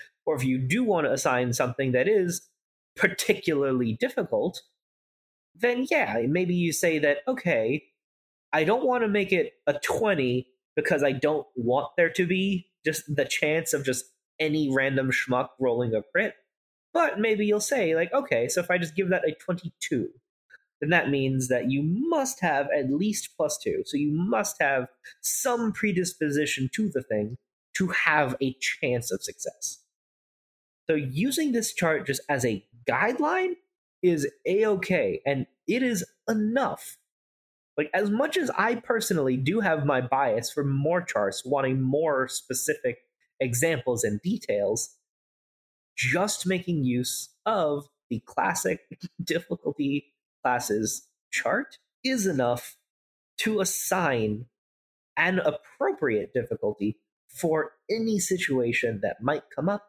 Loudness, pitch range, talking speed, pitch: -26 LUFS, 130-205 Hz, 140 wpm, 155 Hz